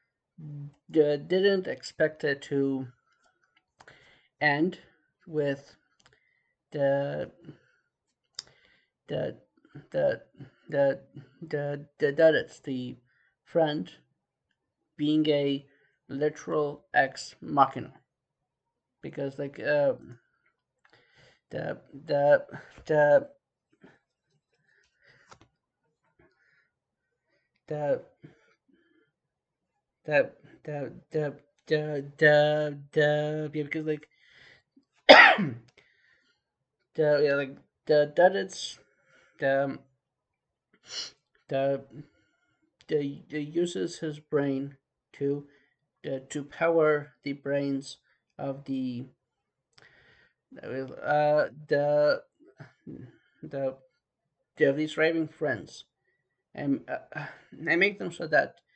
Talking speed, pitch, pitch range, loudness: 75 wpm, 150 Hz, 140-155 Hz, -27 LUFS